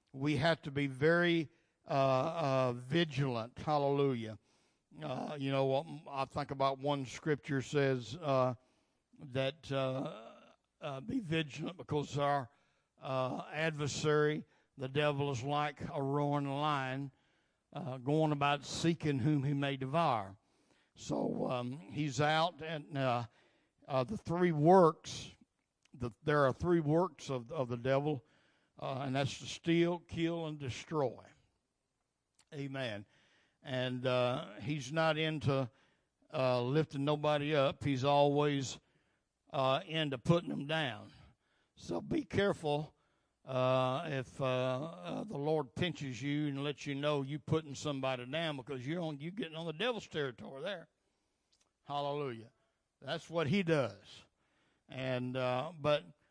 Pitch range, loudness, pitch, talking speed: 130-155 Hz, -35 LUFS, 145 Hz, 130 wpm